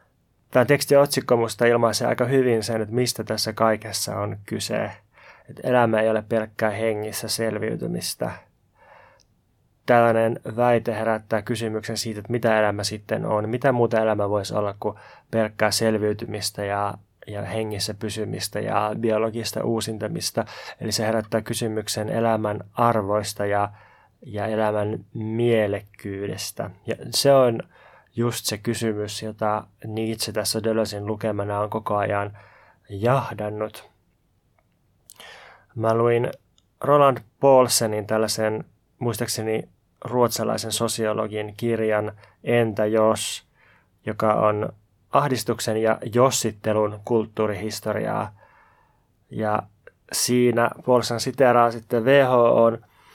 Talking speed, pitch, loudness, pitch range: 105 wpm, 110 Hz, -23 LUFS, 105-115 Hz